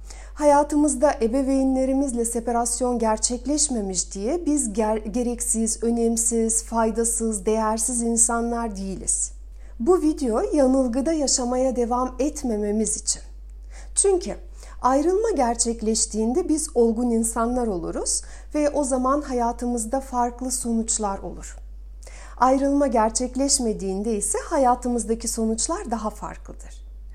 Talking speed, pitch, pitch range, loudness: 90 wpm, 235 Hz, 225-265 Hz, -22 LUFS